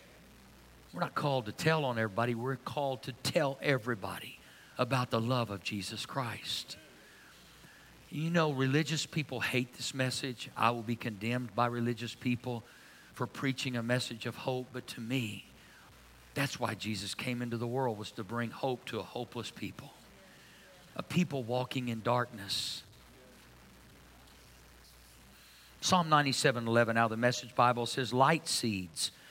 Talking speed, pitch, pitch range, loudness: 145 wpm, 120 Hz, 115-135 Hz, -33 LUFS